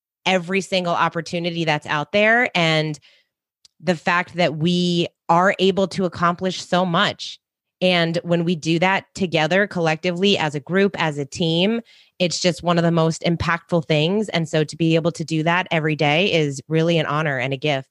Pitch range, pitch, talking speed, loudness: 160-185 Hz, 170 Hz, 185 wpm, -20 LUFS